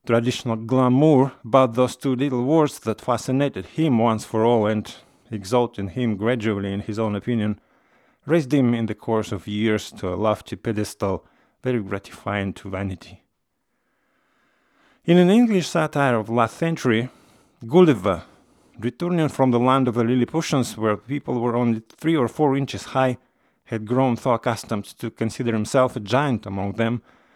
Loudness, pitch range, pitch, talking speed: -22 LUFS, 110-130 Hz, 120 Hz, 160 wpm